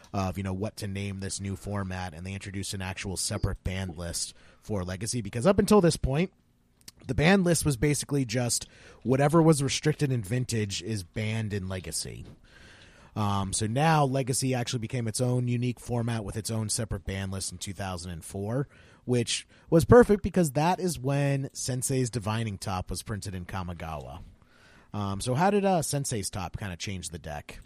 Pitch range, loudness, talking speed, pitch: 95-130 Hz, -28 LUFS, 180 wpm, 110 Hz